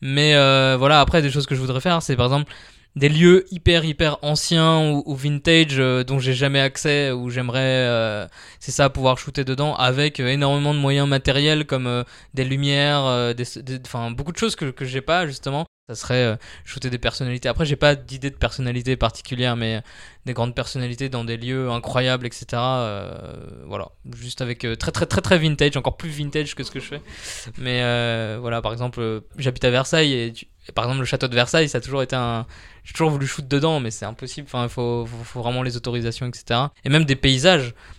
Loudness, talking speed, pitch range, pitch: -20 LUFS, 220 wpm, 120-145 Hz, 130 Hz